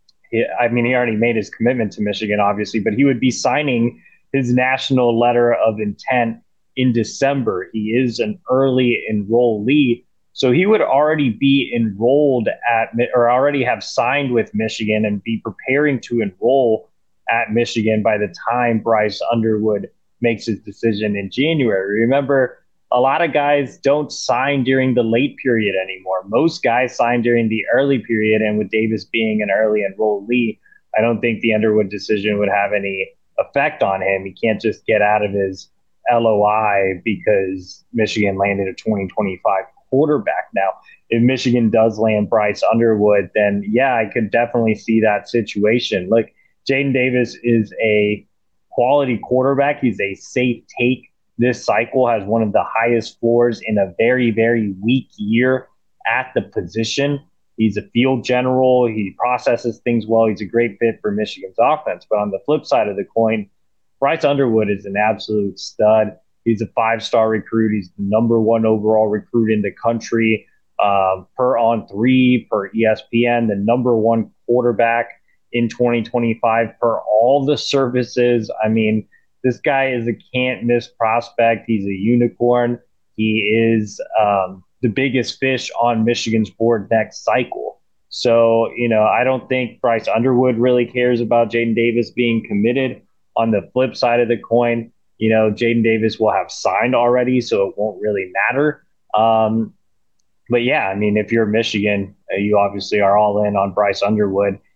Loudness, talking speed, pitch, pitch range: -17 LUFS, 165 wpm, 115 Hz, 105-125 Hz